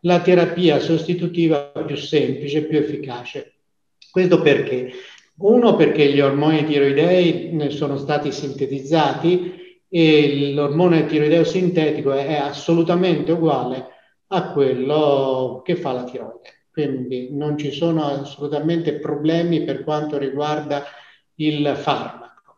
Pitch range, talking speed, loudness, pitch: 140-165 Hz, 110 wpm, -19 LUFS, 150 Hz